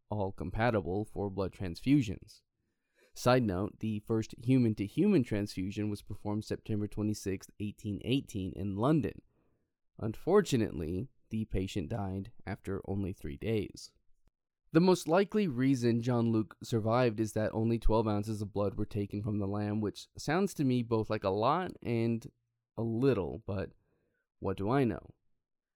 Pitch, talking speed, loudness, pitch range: 110 Hz, 145 wpm, -33 LUFS, 100-120 Hz